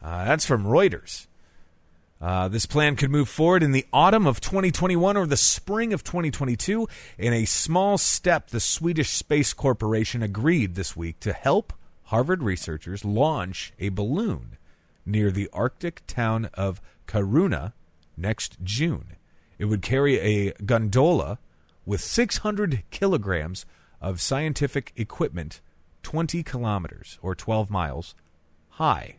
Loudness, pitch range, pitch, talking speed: -24 LUFS, 85-145 Hz, 110 Hz, 130 wpm